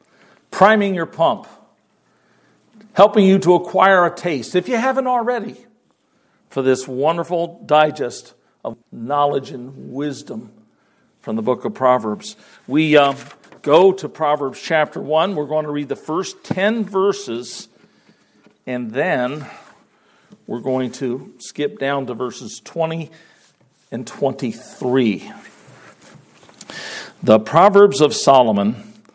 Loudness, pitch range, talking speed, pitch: -18 LUFS, 135-195 Hz, 115 wpm, 155 Hz